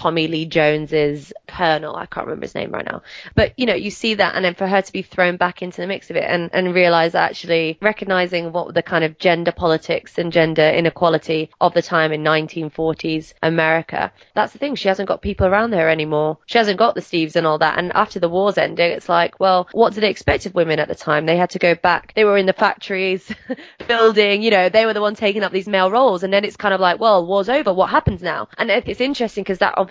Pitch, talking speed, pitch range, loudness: 180 Hz, 250 wpm, 160-200 Hz, -18 LUFS